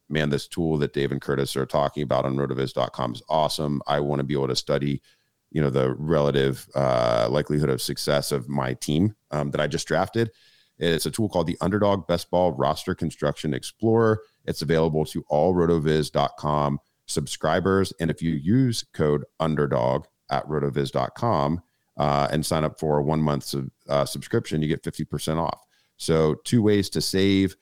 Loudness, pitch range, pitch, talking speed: -24 LUFS, 70-85 Hz, 75 Hz, 180 wpm